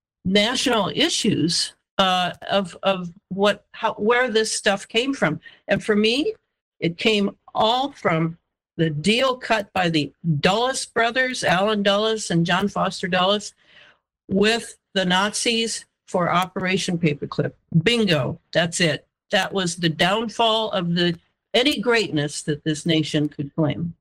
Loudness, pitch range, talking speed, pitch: -21 LUFS, 170-220 Hz, 135 wpm, 195 Hz